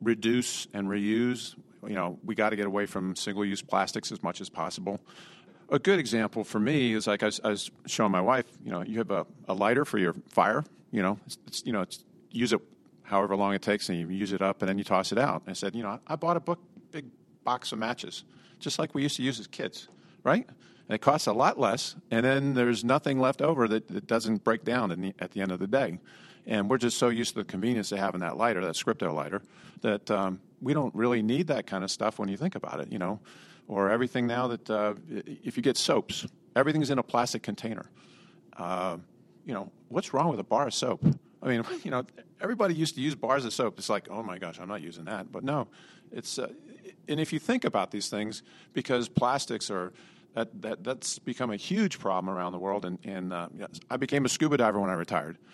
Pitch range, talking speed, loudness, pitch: 100-130 Hz, 240 wpm, -30 LUFS, 110 Hz